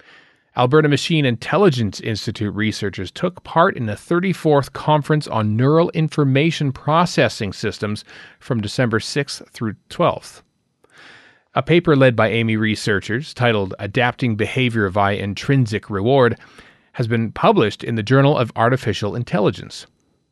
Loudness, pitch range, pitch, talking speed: -18 LUFS, 110-145 Hz, 120 Hz, 125 wpm